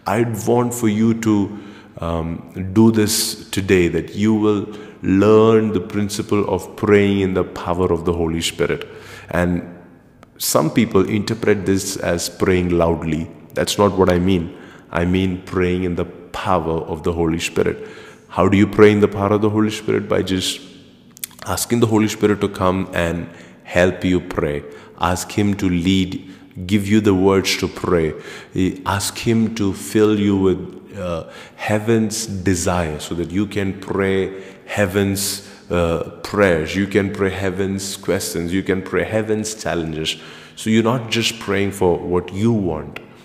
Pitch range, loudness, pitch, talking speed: 90-105 Hz, -19 LUFS, 95 Hz, 160 wpm